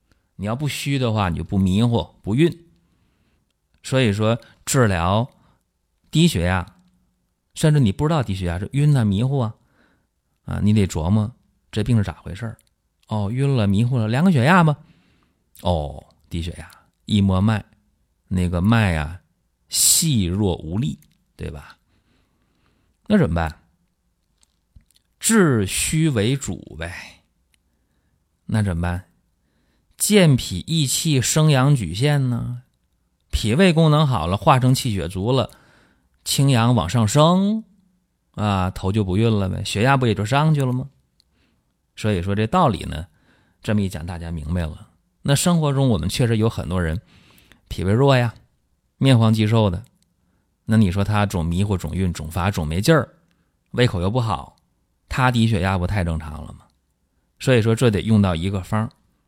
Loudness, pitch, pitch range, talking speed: -20 LUFS, 100 Hz, 85-125 Hz, 210 characters per minute